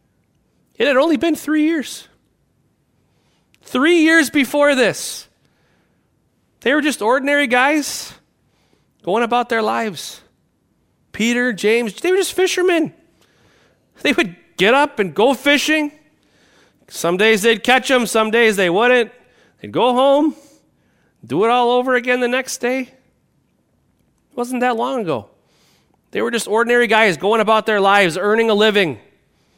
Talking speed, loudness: 140 wpm, -16 LUFS